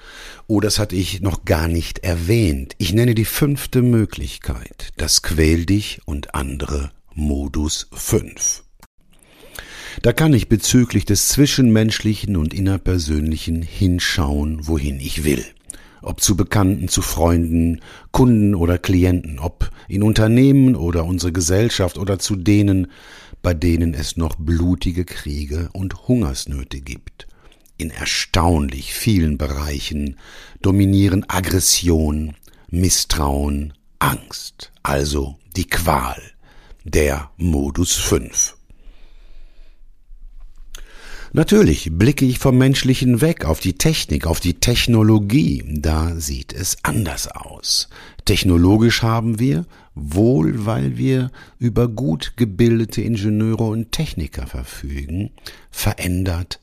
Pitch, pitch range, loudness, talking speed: 90 Hz, 80-110 Hz, -18 LUFS, 110 wpm